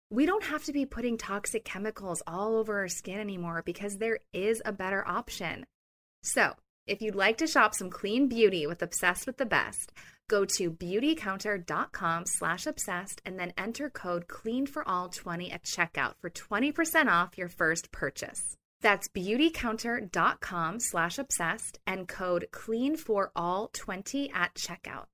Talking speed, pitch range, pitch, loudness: 160 wpm, 180-235 Hz, 205 Hz, -31 LUFS